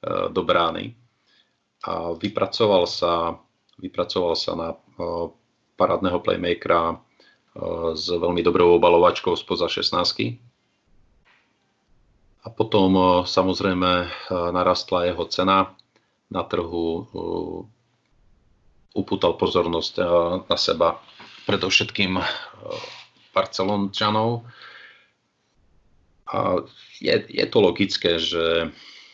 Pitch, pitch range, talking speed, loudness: 95 Hz, 85-110 Hz, 80 wpm, -22 LUFS